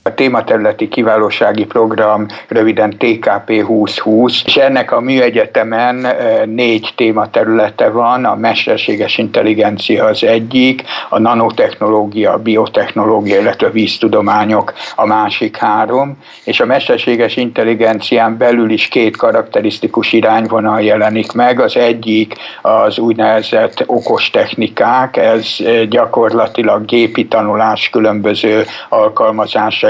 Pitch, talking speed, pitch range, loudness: 115 Hz, 105 wpm, 110-120 Hz, -11 LUFS